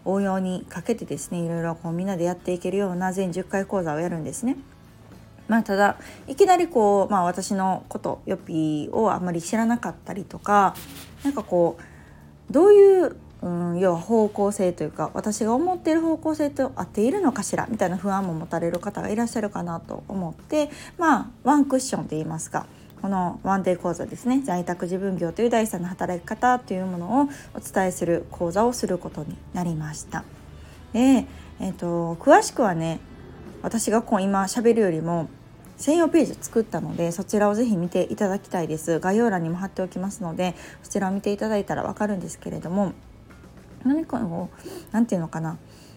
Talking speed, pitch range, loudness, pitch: 375 characters per minute, 175-230 Hz, -24 LUFS, 195 Hz